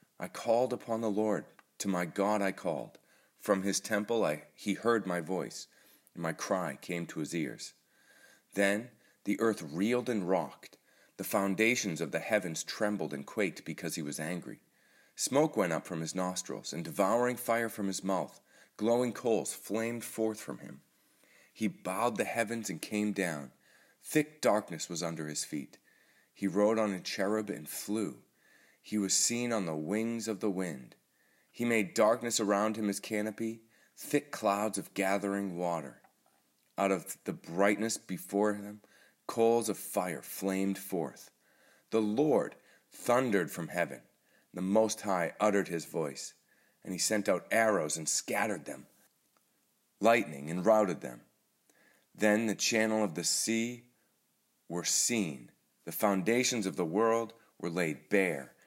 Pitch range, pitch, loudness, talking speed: 95-110 Hz, 105 Hz, -32 LUFS, 155 wpm